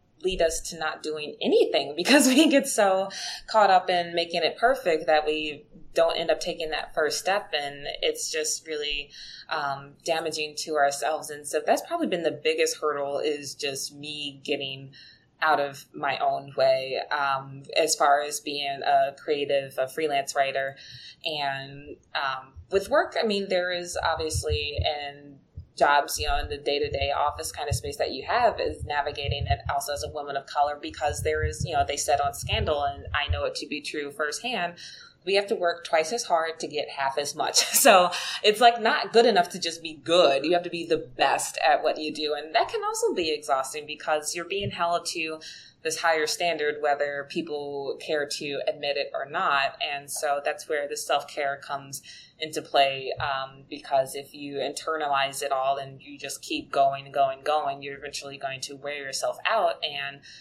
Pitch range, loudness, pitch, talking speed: 140-175 Hz, -26 LUFS, 150 Hz, 200 wpm